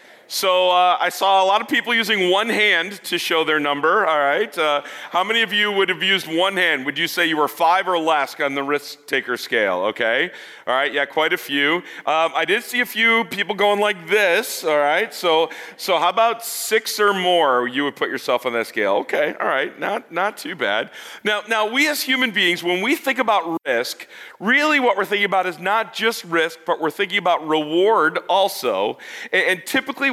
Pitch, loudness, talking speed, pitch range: 190 Hz, -19 LUFS, 215 wpm, 165-225 Hz